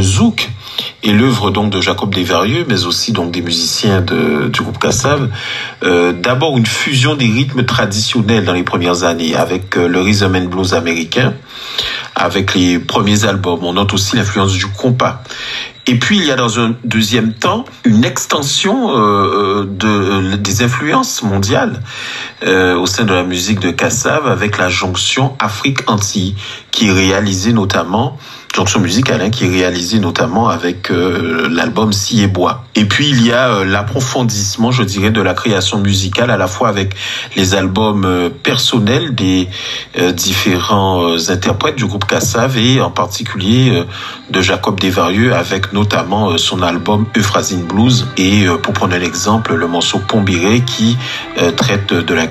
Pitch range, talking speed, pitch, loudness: 95-115 Hz, 170 wpm, 105 Hz, -13 LUFS